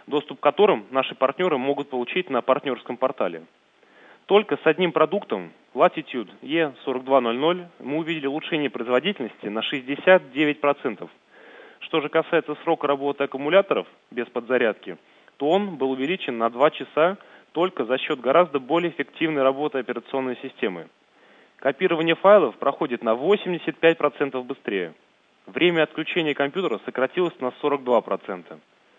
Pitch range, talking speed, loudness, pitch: 130-165 Hz, 120 wpm, -23 LUFS, 145 Hz